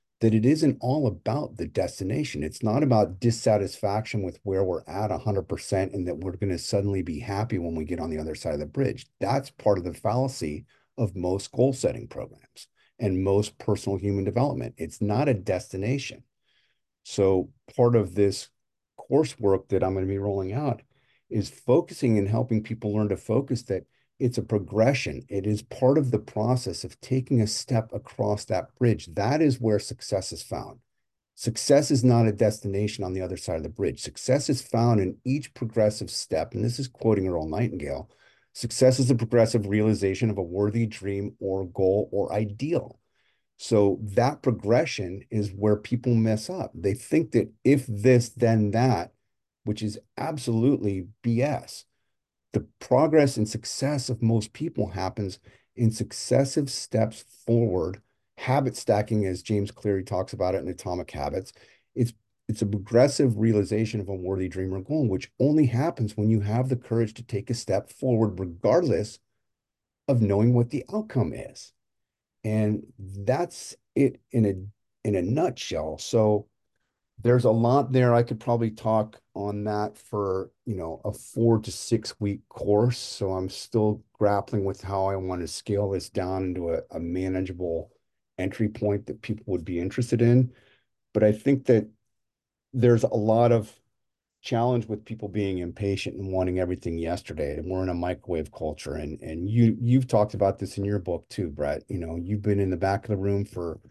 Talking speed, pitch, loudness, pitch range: 175 wpm, 105 Hz, -26 LUFS, 100-120 Hz